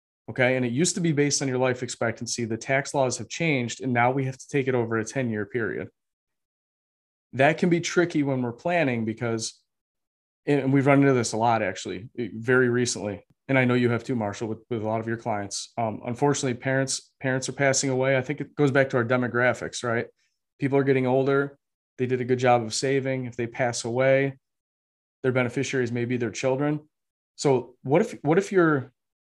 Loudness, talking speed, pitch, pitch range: -25 LUFS, 210 wpm, 130 Hz, 120-135 Hz